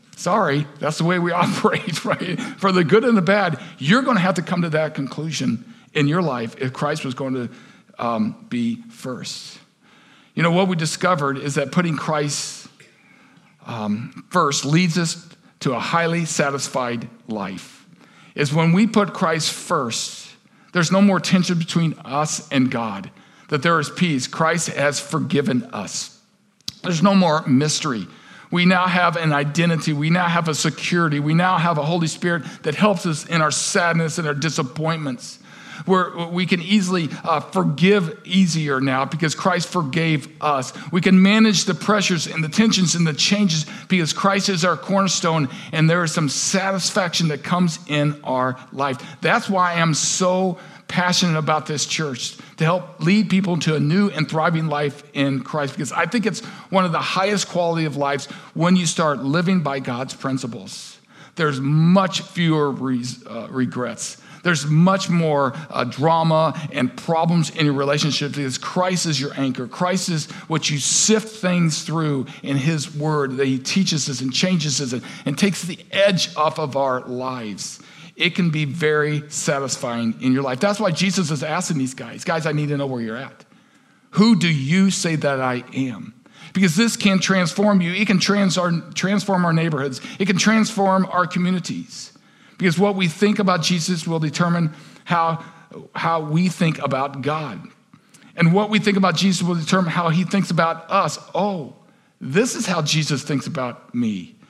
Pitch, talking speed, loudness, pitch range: 165 Hz, 175 wpm, -20 LUFS, 150-185 Hz